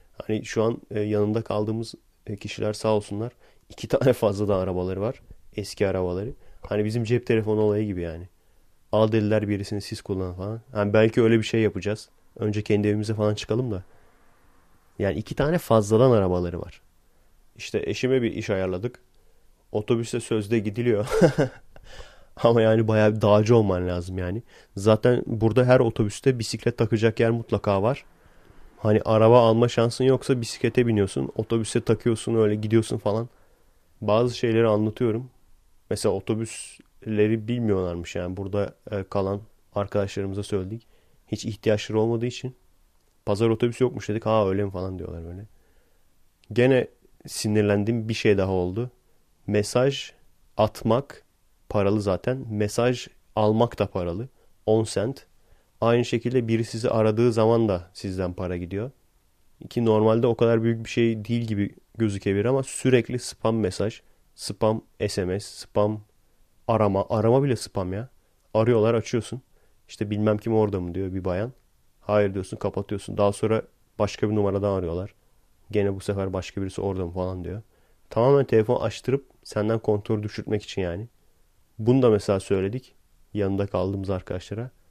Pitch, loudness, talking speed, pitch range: 105 Hz, -24 LUFS, 140 wpm, 100-115 Hz